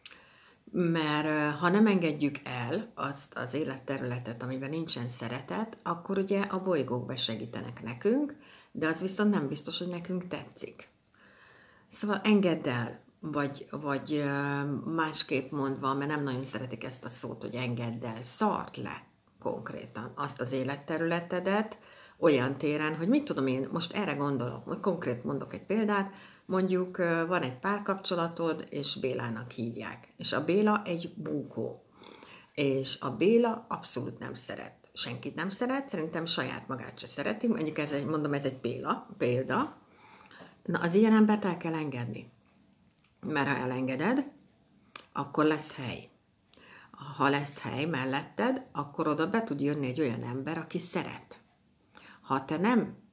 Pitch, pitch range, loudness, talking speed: 155 Hz, 135-185 Hz, -32 LUFS, 140 wpm